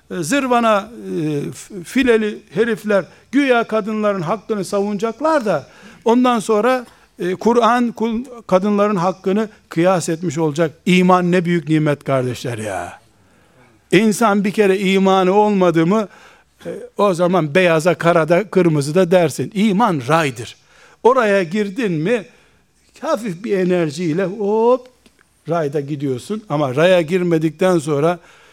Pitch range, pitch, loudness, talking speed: 170-220 Hz, 190 Hz, -17 LUFS, 105 wpm